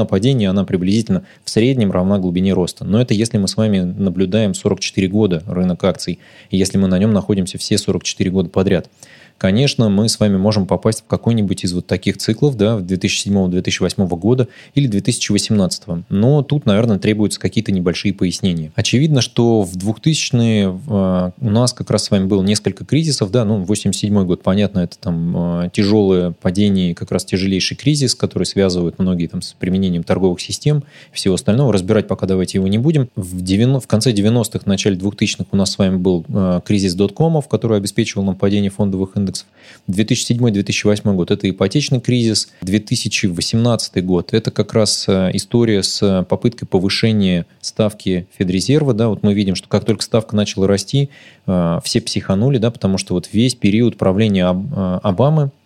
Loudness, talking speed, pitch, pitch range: -16 LUFS, 165 wpm, 100 Hz, 95-115 Hz